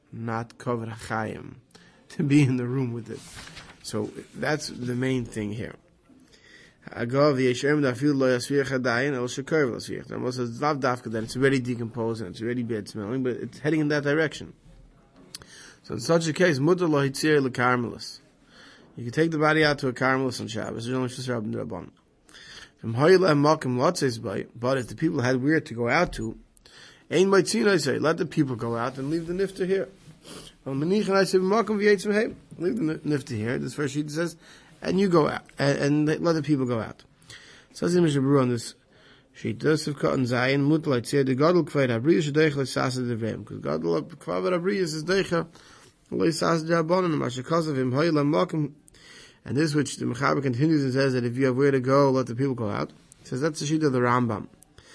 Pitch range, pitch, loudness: 125-160 Hz, 140 Hz, -25 LUFS